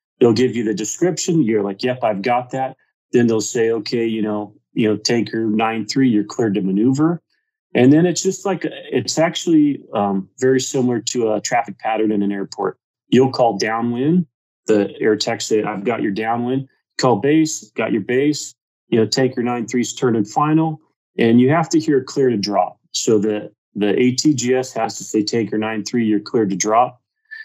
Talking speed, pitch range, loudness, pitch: 195 wpm, 110-145 Hz, -18 LUFS, 120 Hz